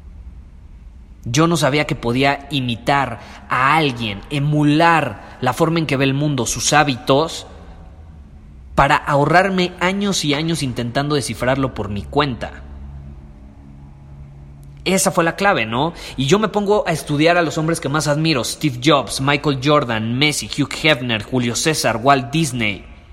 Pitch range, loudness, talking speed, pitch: 95-155 Hz, -17 LUFS, 145 wpm, 135 Hz